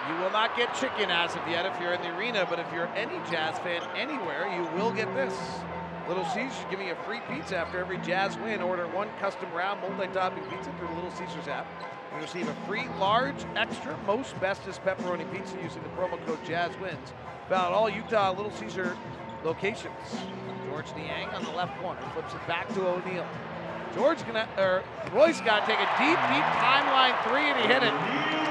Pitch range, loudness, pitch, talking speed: 175-190 Hz, -29 LUFS, 185 Hz, 195 wpm